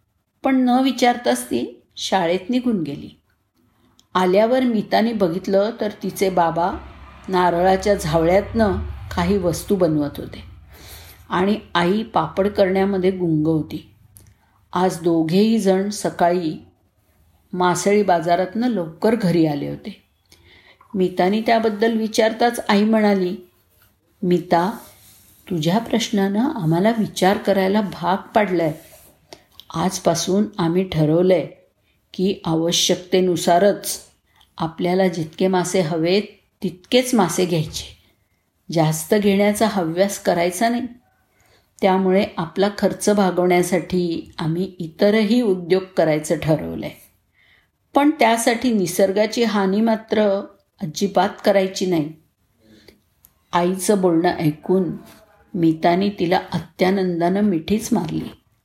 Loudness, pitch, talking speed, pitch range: -19 LUFS, 185 Hz, 95 wpm, 165-205 Hz